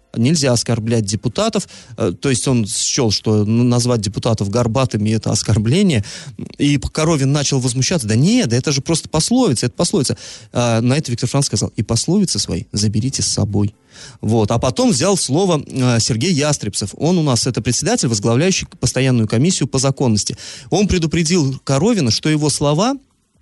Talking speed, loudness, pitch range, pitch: 155 wpm, -16 LUFS, 115-150 Hz, 125 Hz